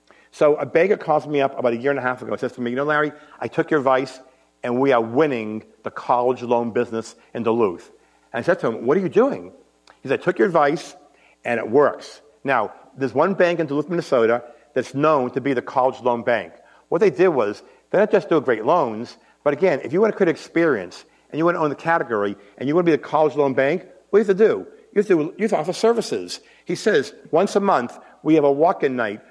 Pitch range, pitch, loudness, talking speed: 125-165 Hz, 140 Hz, -20 LUFS, 260 wpm